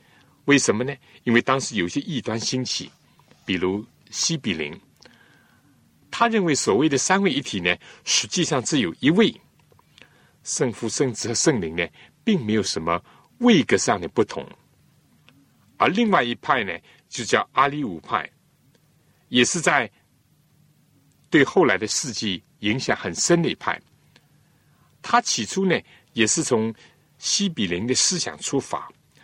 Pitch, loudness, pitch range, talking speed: 130 Hz, -22 LUFS, 110-165 Hz, 205 characters per minute